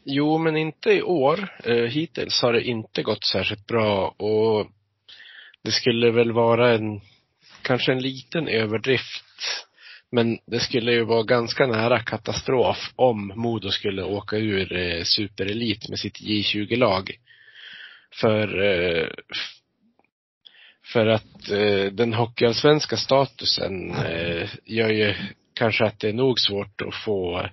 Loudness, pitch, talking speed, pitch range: -23 LUFS, 115 Hz, 120 wpm, 105-130 Hz